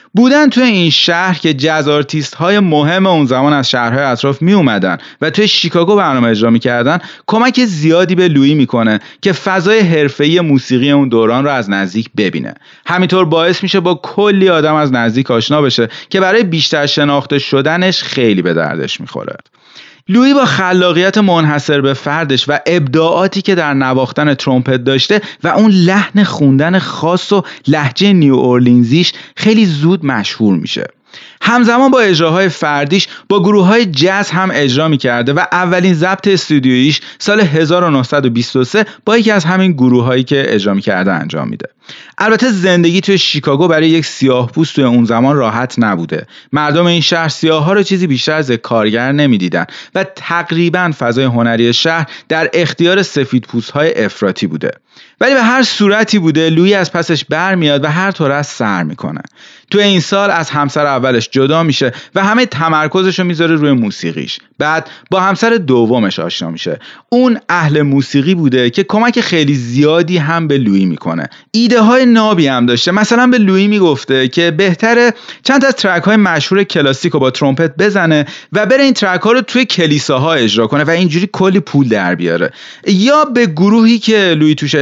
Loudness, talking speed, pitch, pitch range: -11 LUFS, 170 wpm, 165 Hz, 140-195 Hz